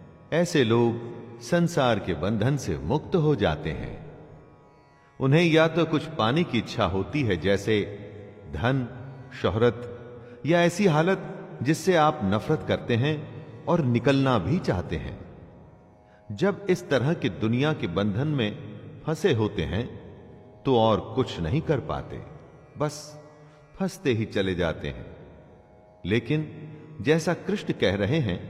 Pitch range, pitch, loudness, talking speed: 105-155 Hz, 130 Hz, -25 LUFS, 135 wpm